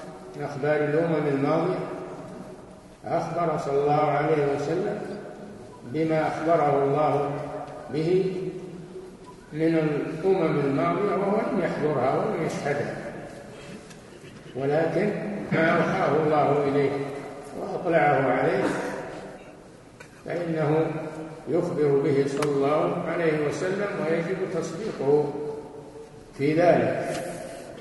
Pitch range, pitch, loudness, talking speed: 145-170 Hz, 155 Hz, -25 LUFS, 85 wpm